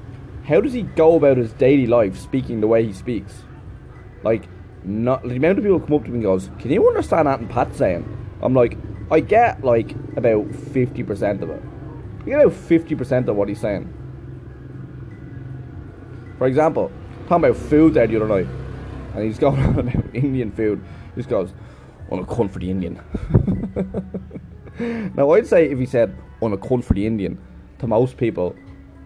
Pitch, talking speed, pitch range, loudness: 120 Hz, 190 wpm, 105-140 Hz, -19 LUFS